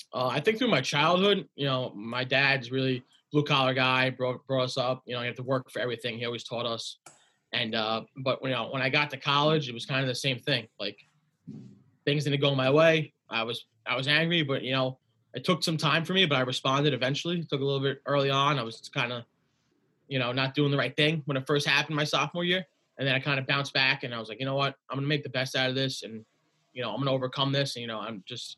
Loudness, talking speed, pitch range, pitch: -27 LUFS, 275 wpm, 125-145 Hz, 135 Hz